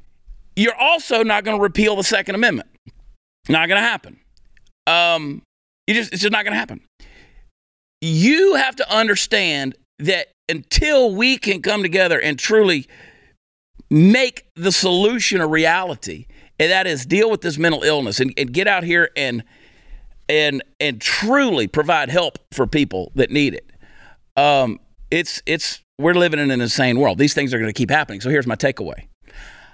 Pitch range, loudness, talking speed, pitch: 140-210 Hz, -17 LUFS, 165 wpm, 170 Hz